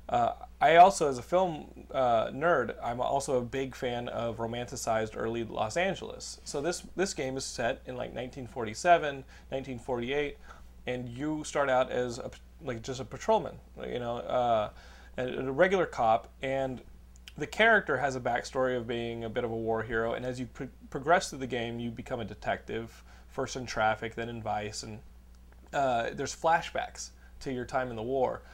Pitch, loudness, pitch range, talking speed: 125 Hz, -31 LUFS, 115-135 Hz, 185 wpm